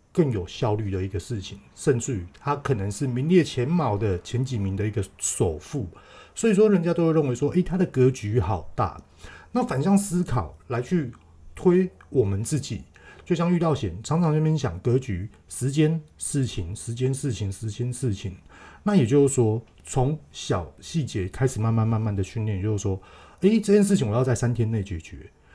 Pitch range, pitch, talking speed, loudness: 100-155 Hz, 120 Hz, 275 characters per minute, -25 LUFS